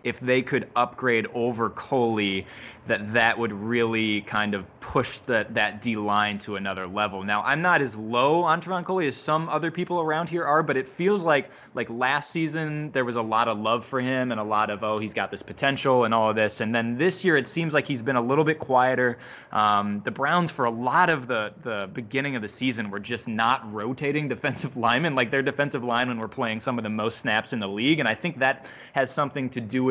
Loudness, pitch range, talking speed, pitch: -25 LUFS, 110-140 Hz, 235 wpm, 125 Hz